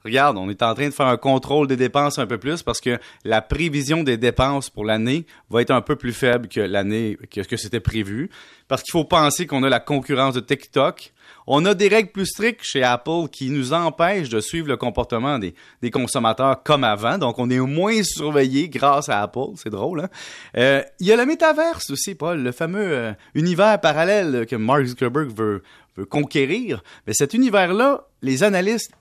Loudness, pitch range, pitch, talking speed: -20 LUFS, 120-165 Hz, 140 Hz, 205 wpm